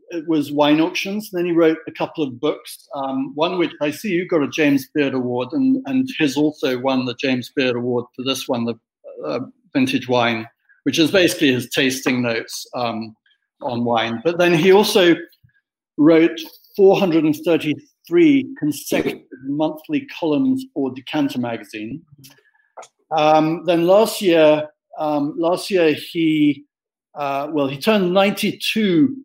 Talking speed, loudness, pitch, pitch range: 160 wpm, -19 LUFS, 160 Hz, 140-205 Hz